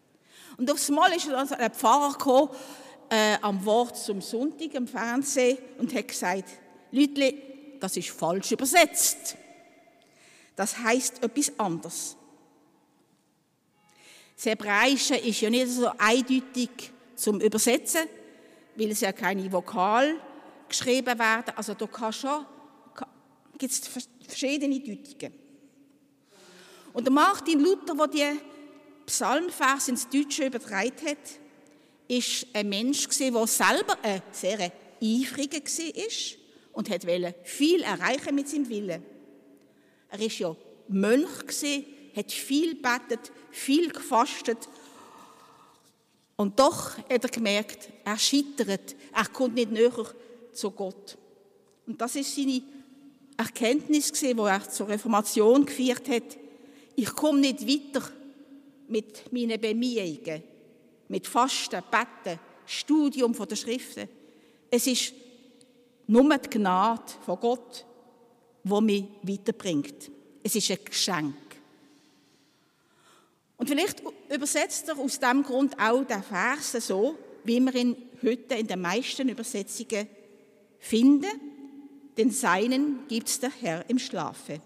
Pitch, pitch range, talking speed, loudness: 245 Hz, 220-280 Hz, 120 wpm, -27 LUFS